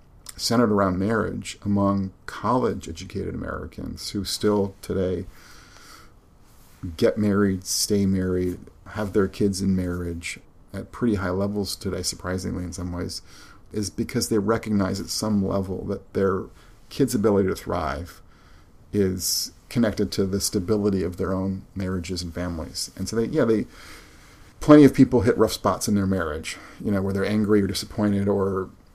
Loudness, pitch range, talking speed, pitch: -24 LUFS, 90-105 Hz, 150 wpm, 95 Hz